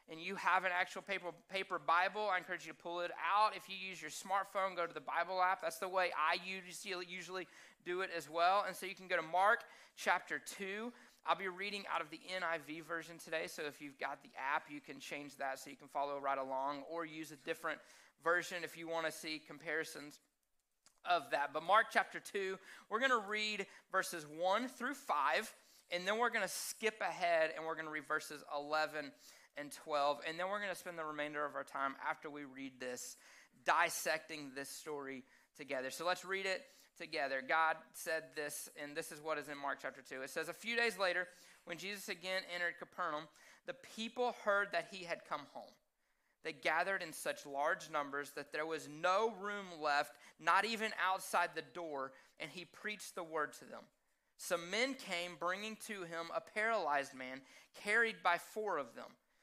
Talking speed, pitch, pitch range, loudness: 205 wpm, 170 Hz, 150-190 Hz, -39 LUFS